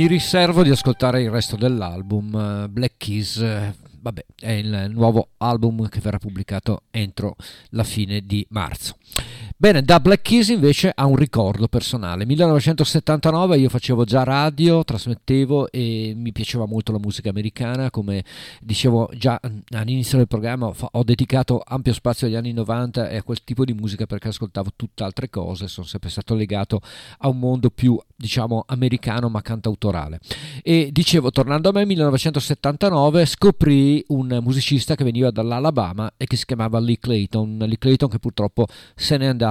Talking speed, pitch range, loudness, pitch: 165 wpm, 110-135 Hz, -20 LUFS, 120 Hz